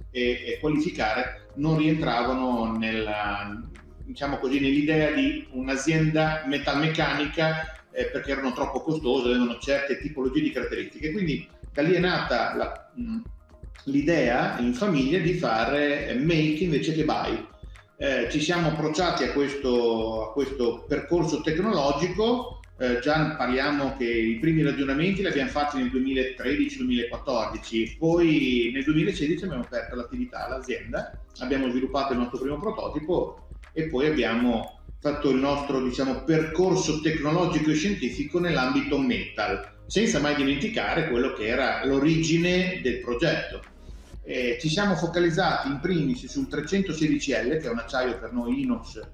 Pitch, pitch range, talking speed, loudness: 145 Hz, 125-165 Hz, 135 wpm, -26 LUFS